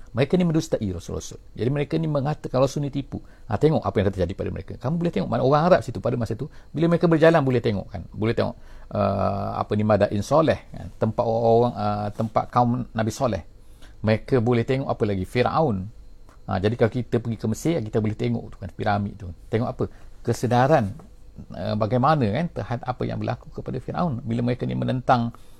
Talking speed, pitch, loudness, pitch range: 200 wpm, 115 Hz, -24 LUFS, 100-130 Hz